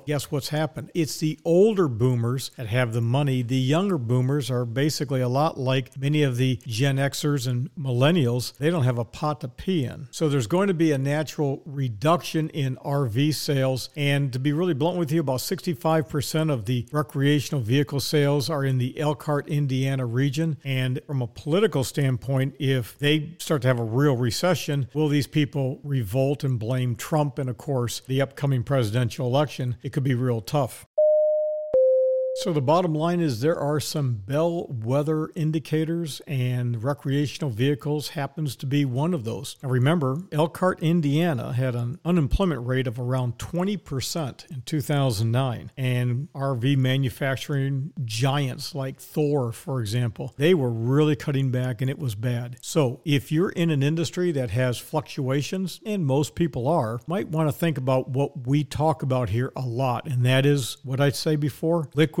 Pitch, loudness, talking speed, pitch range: 140 Hz, -25 LUFS, 175 wpm, 130-155 Hz